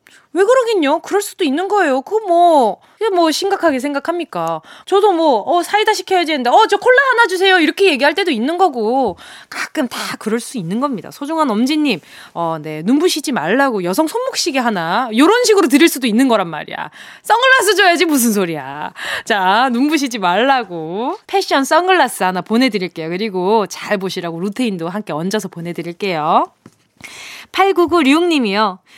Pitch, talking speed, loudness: 280 Hz, 360 characters per minute, -15 LUFS